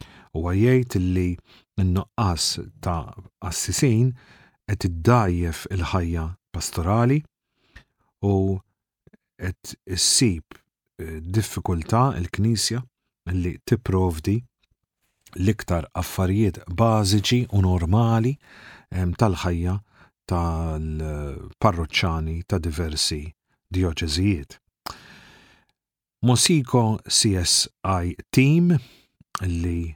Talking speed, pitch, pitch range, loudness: 60 wpm, 95 Hz, 85-115 Hz, -23 LUFS